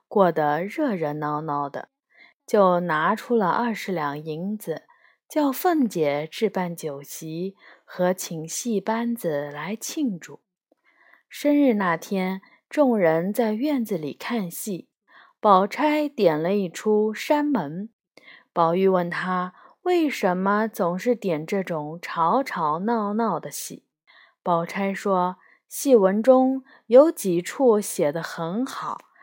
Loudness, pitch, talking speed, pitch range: -23 LUFS, 195 Hz, 170 characters per minute, 170-235 Hz